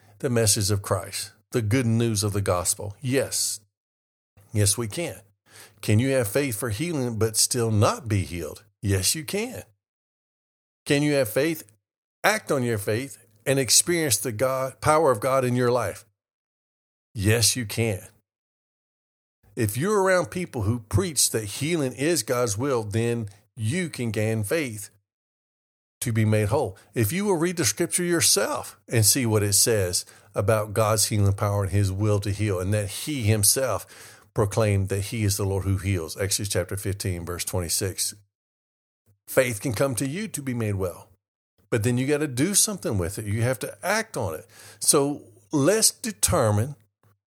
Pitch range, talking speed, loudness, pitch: 100-130 Hz, 170 wpm, -24 LUFS, 110 Hz